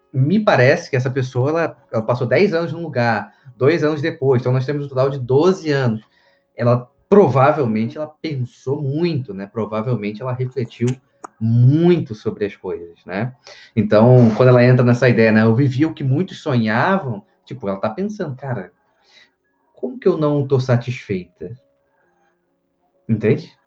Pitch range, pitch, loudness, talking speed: 115-150 Hz, 130 Hz, -17 LUFS, 155 wpm